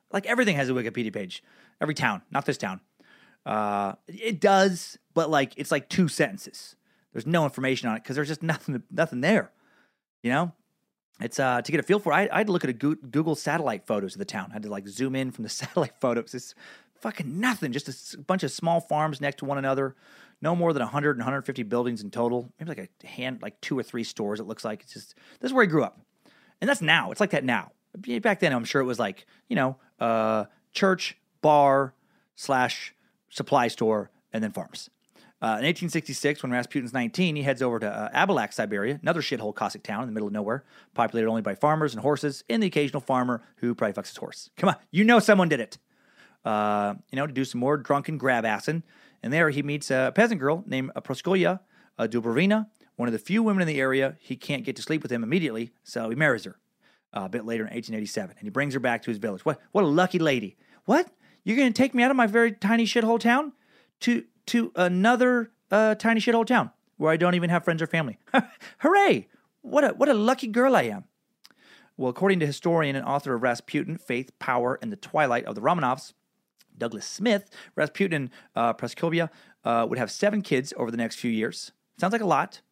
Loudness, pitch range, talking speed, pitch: -26 LUFS, 125-195 Hz, 225 wpm, 150 Hz